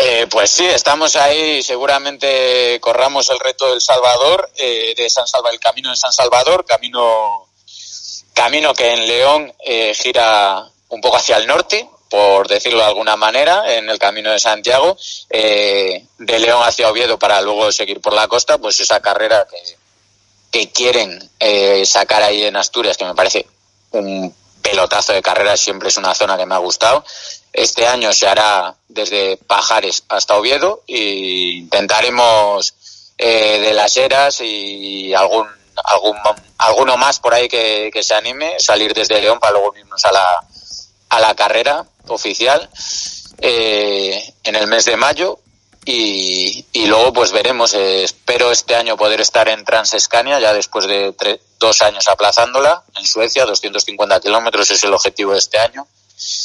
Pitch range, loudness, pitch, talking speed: 100-140 Hz, -13 LUFS, 110 Hz, 160 wpm